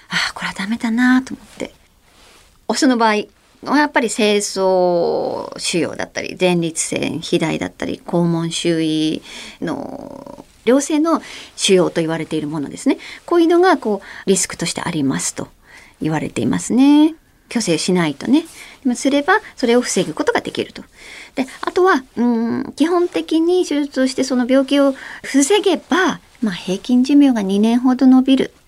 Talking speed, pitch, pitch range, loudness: 310 characters per minute, 250 Hz, 185-290 Hz, -17 LUFS